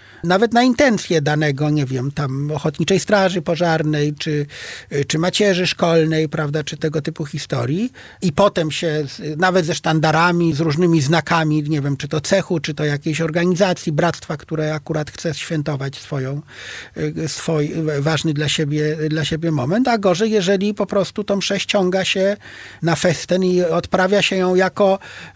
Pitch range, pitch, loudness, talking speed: 155-185 Hz, 165 Hz, -18 LUFS, 155 wpm